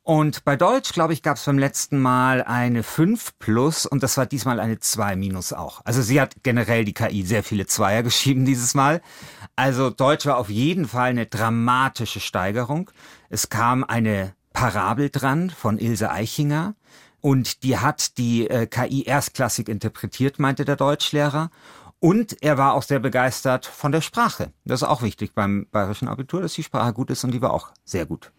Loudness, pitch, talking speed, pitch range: -22 LUFS, 130 Hz, 185 wpm, 115-145 Hz